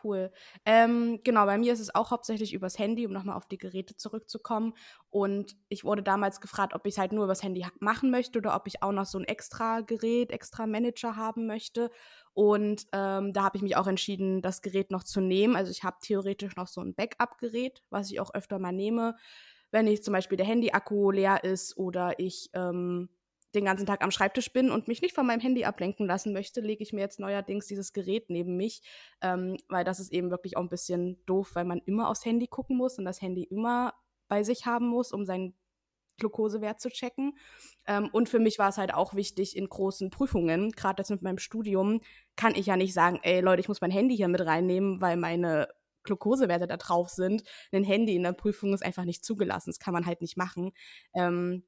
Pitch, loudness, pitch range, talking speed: 200 Hz, -30 LUFS, 185-225 Hz, 220 wpm